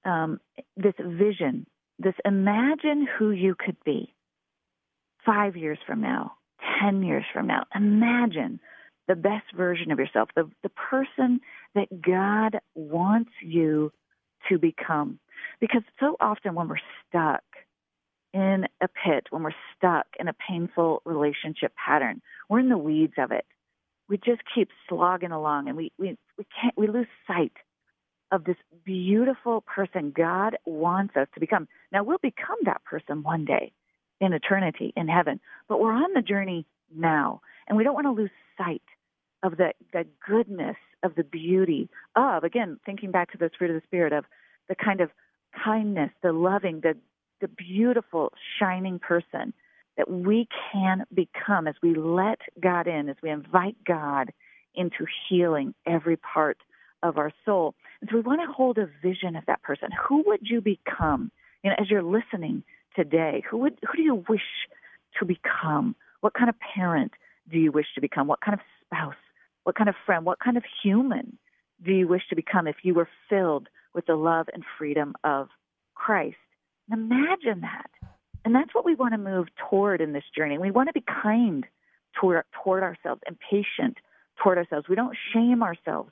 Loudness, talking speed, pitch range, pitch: -26 LUFS, 170 wpm, 170-225 Hz, 190 Hz